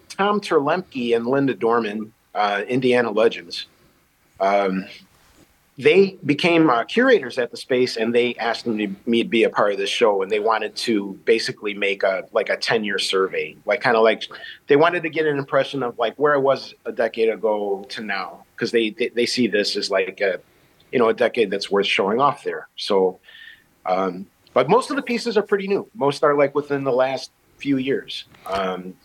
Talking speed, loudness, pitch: 200 wpm, -21 LUFS, 135 Hz